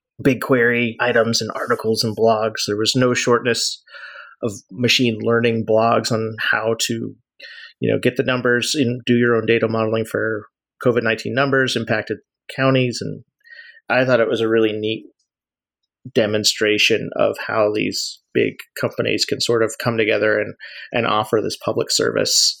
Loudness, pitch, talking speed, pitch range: -18 LUFS, 115 Hz, 155 wpm, 110-125 Hz